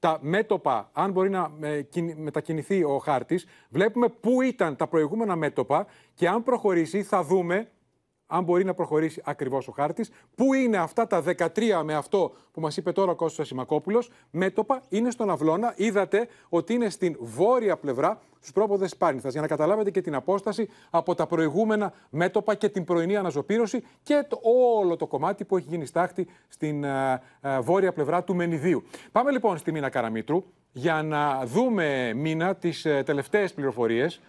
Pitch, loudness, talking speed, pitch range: 180 Hz, -26 LUFS, 160 wpm, 155-210 Hz